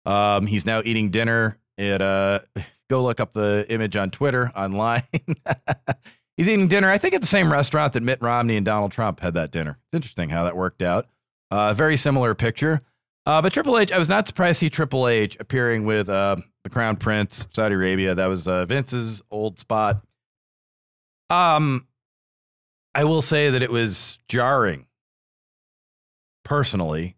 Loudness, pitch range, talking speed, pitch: -22 LUFS, 100-140 Hz, 170 wpm, 115 Hz